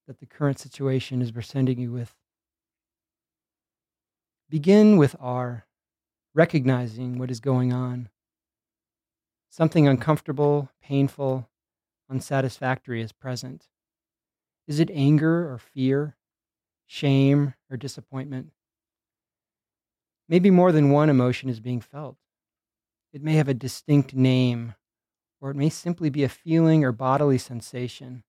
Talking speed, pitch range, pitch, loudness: 115 wpm, 125-145 Hz, 135 Hz, -23 LUFS